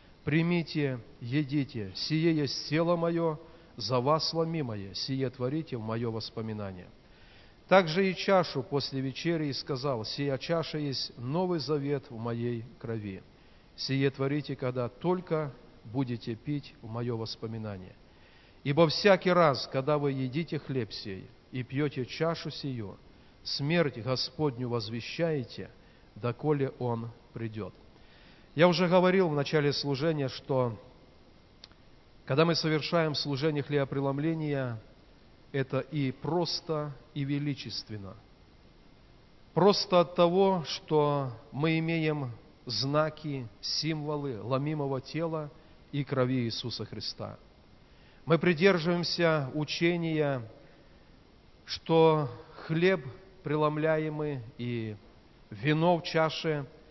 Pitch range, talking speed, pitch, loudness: 120-160 Hz, 100 wpm, 145 Hz, -30 LUFS